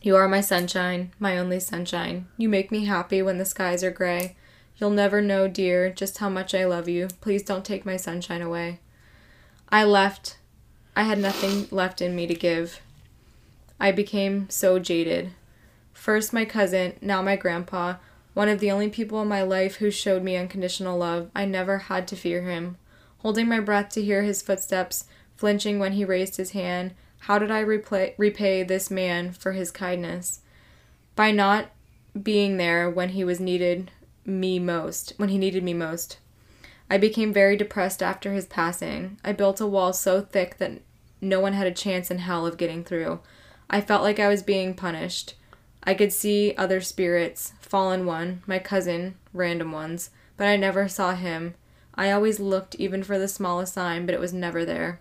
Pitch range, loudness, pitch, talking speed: 180-200 Hz, -25 LUFS, 190 Hz, 185 wpm